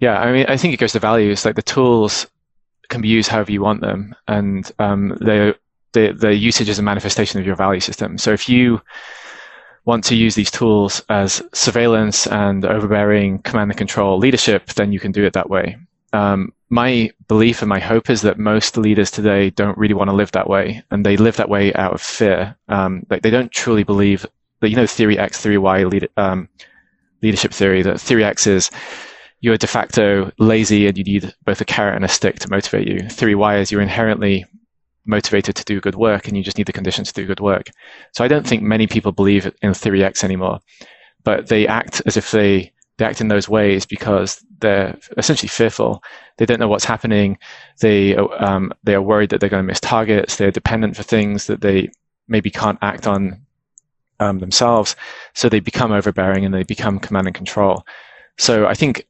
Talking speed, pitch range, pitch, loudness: 205 wpm, 100-110 Hz, 105 Hz, -16 LUFS